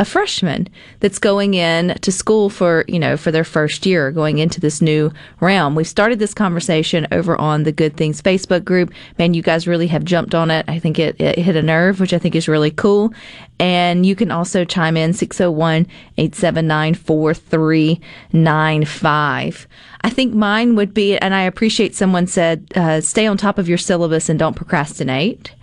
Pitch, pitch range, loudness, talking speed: 170 Hz, 160-190 Hz, -16 LUFS, 185 wpm